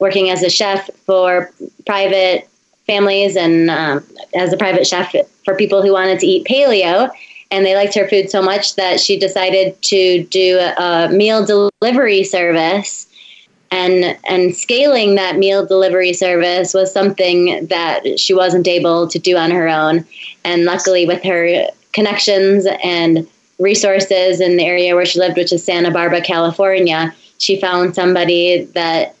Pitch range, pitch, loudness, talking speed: 175-195 Hz, 185 Hz, -13 LUFS, 155 wpm